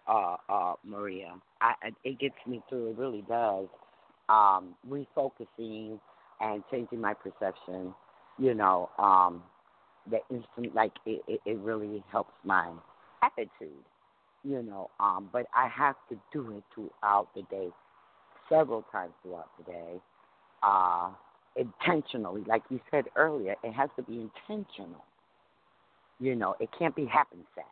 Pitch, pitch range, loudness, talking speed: 110 Hz, 100-125 Hz, -31 LUFS, 140 wpm